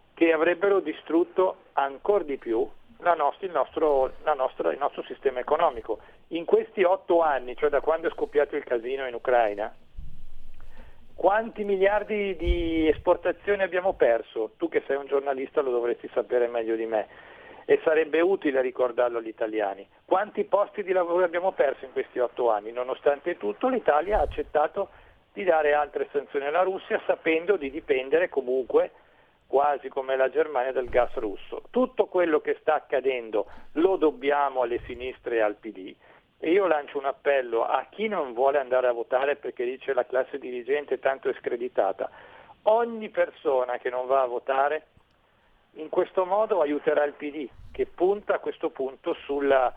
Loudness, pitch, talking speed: -26 LUFS, 175 Hz, 165 wpm